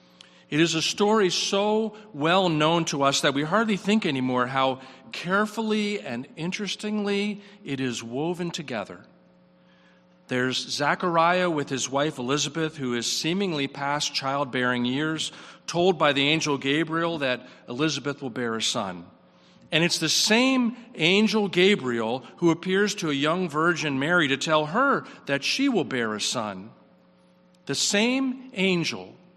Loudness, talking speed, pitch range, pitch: -24 LUFS, 145 wpm, 130-190 Hz, 155 Hz